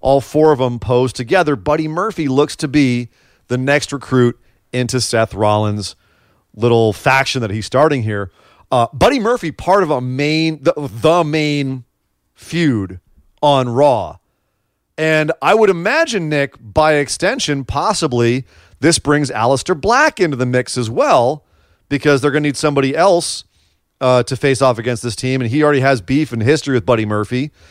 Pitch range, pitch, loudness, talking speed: 115-150 Hz, 130 Hz, -15 LUFS, 165 wpm